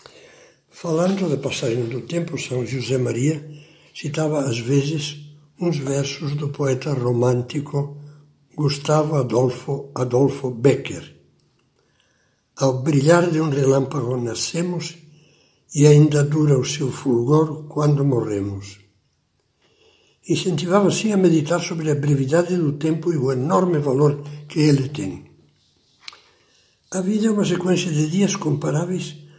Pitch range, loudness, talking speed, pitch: 135-165 Hz, -20 LUFS, 120 wpm, 150 Hz